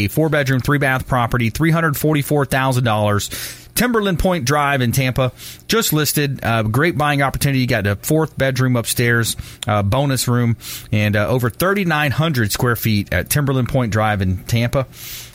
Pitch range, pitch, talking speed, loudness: 115-145 Hz, 130 Hz, 150 wpm, -17 LUFS